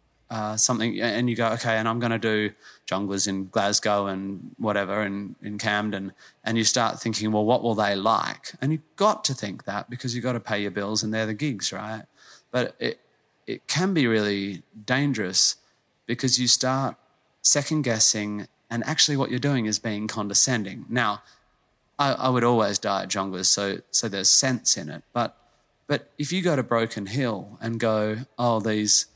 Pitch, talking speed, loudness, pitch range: 110 Hz, 190 wpm, -24 LUFS, 105-125 Hz